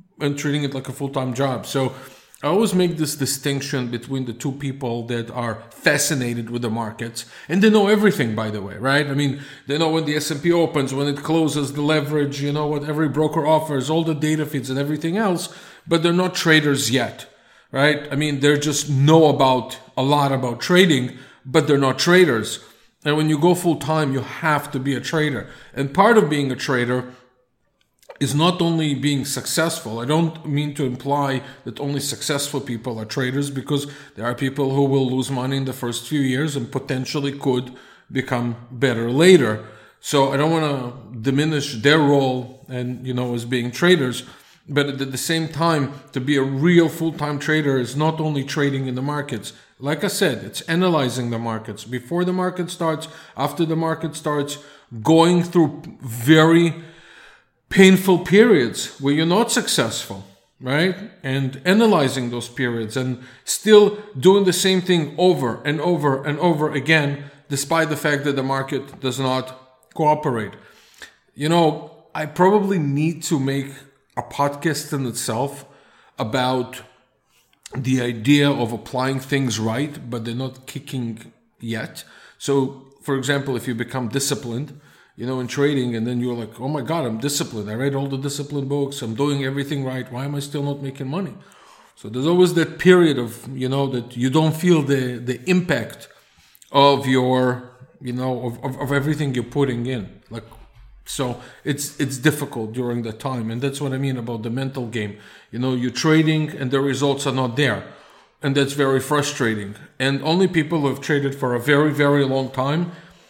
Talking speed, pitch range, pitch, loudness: 185 wpm, 130-155 Hz, 140 Hz, -20 LUFS